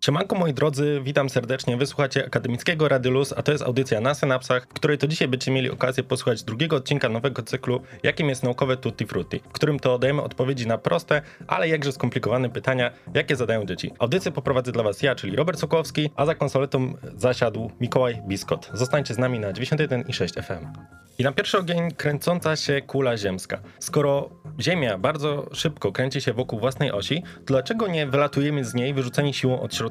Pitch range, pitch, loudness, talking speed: 125-145 Hz, 135 Hz, -24 LUFS, 185 wpm